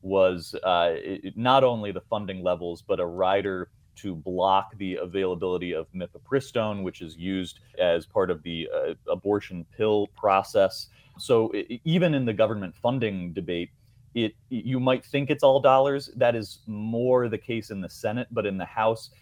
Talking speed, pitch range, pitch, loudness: 170 wpm, 95-125 Hz, 105 Hz, -26 LUFS